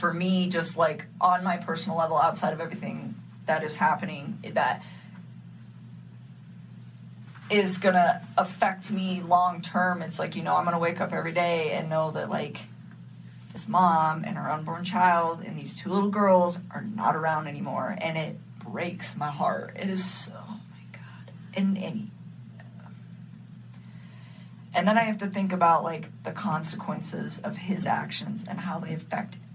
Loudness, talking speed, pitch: -27 LUFS, 160 wpm, 170 Hz